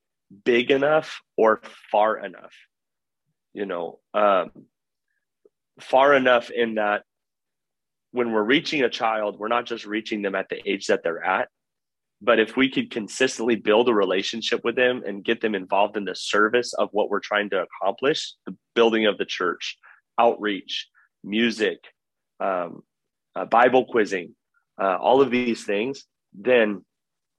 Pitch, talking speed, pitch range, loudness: 115 Hz, 150 wpm, 105-125 Hz, -23 LUFS